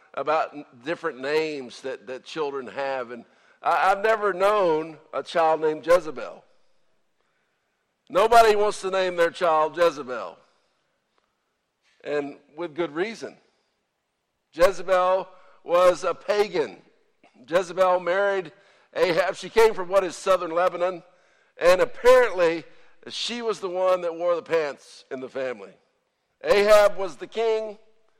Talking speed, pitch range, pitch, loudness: 125 wpm, 170-215 Hz, 185 Hz, -23 LUFS